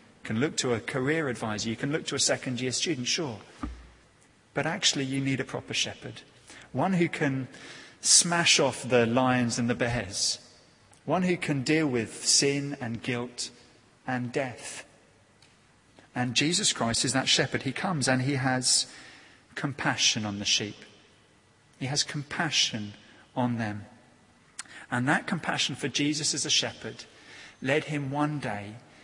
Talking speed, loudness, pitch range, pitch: 155 wpm, -27 LUFS, 115-145 Hz, 130 Hz